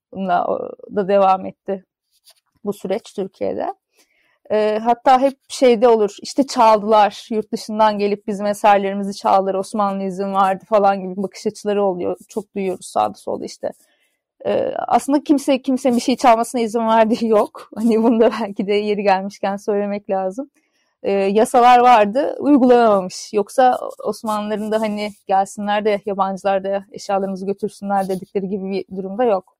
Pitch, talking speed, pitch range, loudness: 210 Hz, 145 wpm, 195-240 Hz, -18 LUFS